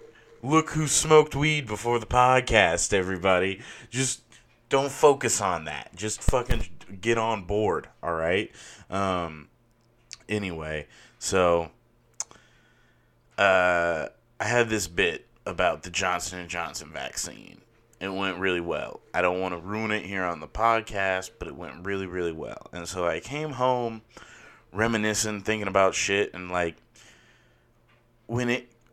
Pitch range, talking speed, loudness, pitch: 90-120 Hz, 135 wpm, -26 LUFS, 105 Hz